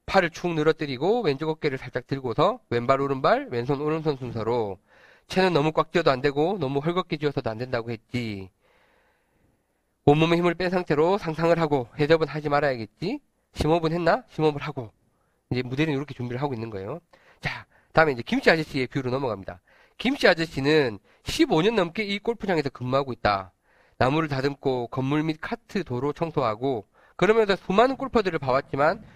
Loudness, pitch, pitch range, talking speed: -25 LUFS, 145 Hz, 125-170 Hz, 375 characters per minute